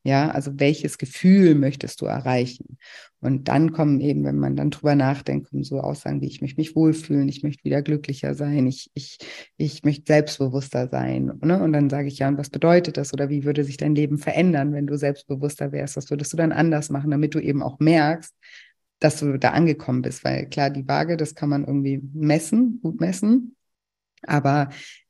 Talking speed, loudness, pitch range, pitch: 200 wpm, -22 LUFS, 140-155 Hz, 145 Hz